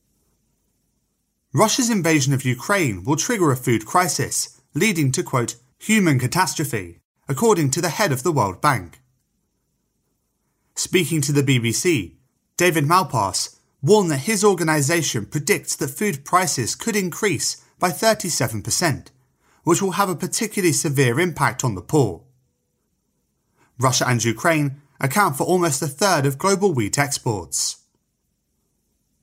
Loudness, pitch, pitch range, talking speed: -20 LUFS, 150 Hz, 125-180 Hz, 125 wpm